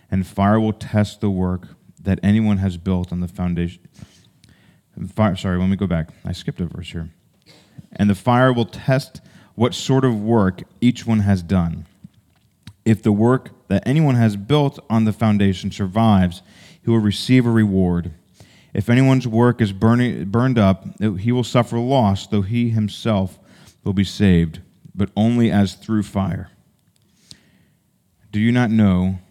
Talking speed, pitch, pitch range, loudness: 160 wpm, 105 Hz, 95-115 Hz, -19 LUFS